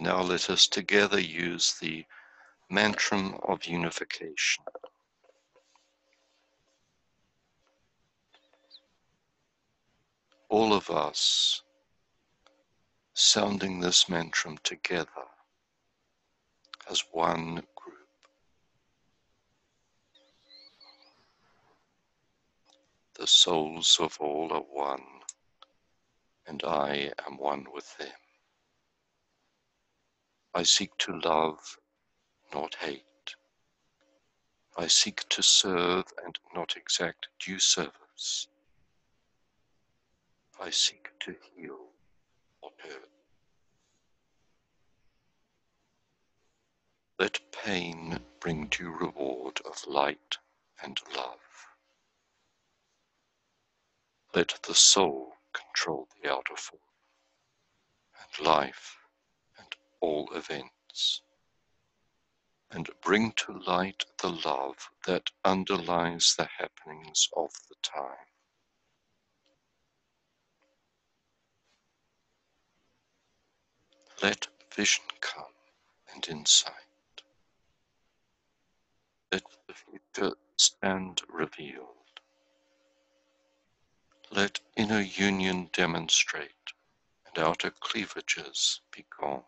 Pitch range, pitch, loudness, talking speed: 60-90 Hz, 80 Hz, -27 LUFS, 70 wpm